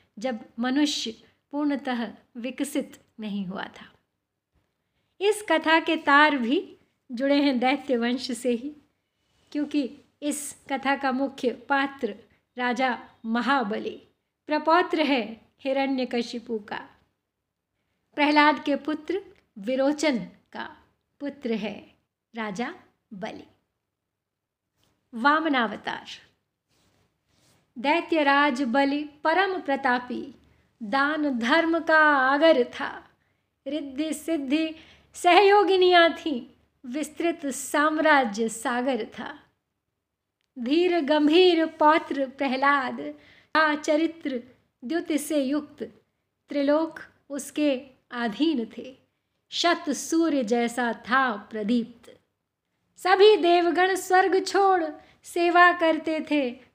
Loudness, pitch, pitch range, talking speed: -24 LUFS, 285 Hz, 250-315 Hz, 90 wpm